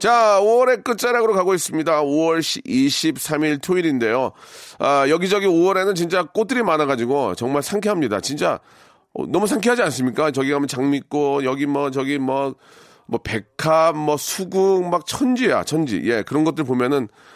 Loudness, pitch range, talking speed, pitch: -19 LUFS, 140-195 Hz, 320 characters per minute, 160 Hz